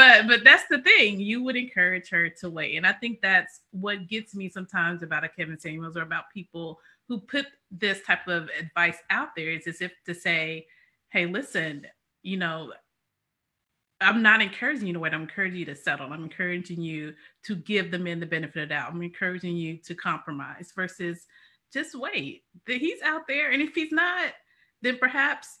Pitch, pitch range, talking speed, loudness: 180 Hz, 165-235 Hz, 195 wpm, -24 LUFS